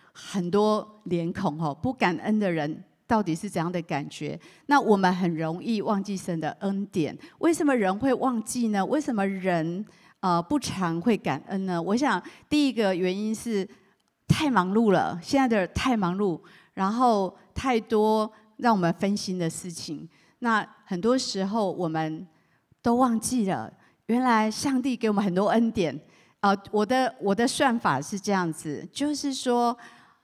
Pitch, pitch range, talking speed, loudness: 200 Hz, 175-235 Hz, 230 characters per minute, -26 LUFS